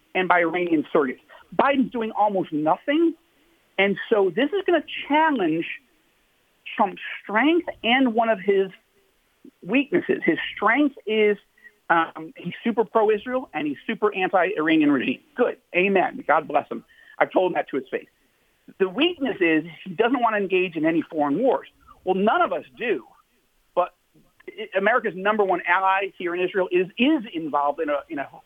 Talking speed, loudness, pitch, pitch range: 165 wpm, -23 LUFS, 220 Hz, 185-295 Hz